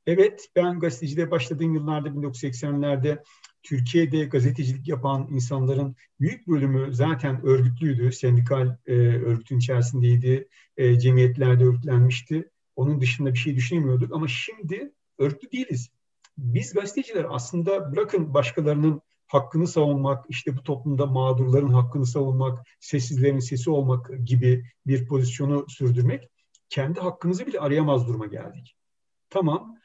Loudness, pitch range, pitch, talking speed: -24 LUFS, 125-155 Hz, 140 Hz, 115 wpm